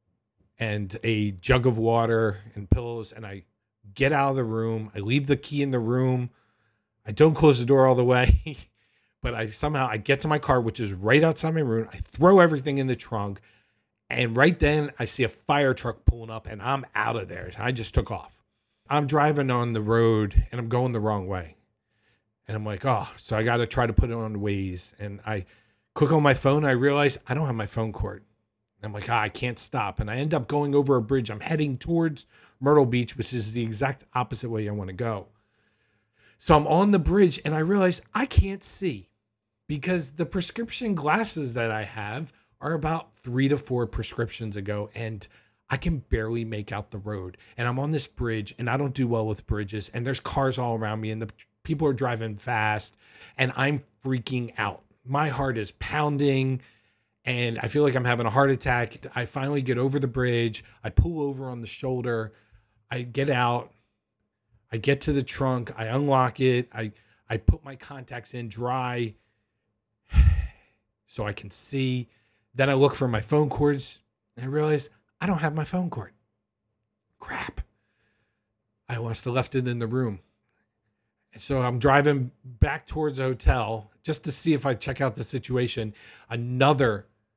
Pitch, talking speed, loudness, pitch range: 120 Hz, 195 wpm, -26 LUFS, 110-135 Hz